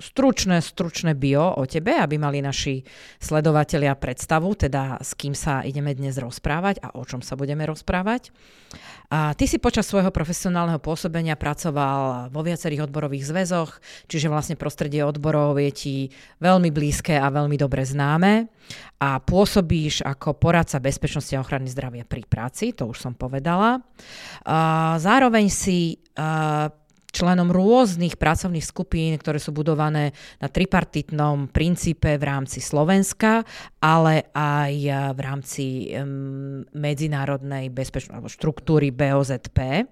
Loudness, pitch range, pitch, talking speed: -22 LUFS, 140-170 Hz, 150 Hz, 130 wpm